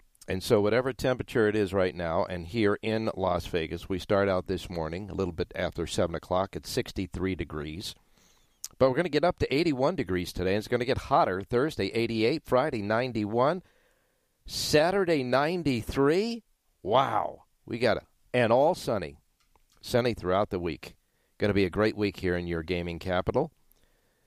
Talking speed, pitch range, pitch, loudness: 175 wpm, 90-125 Hz, 105 Hz, -28 LUFS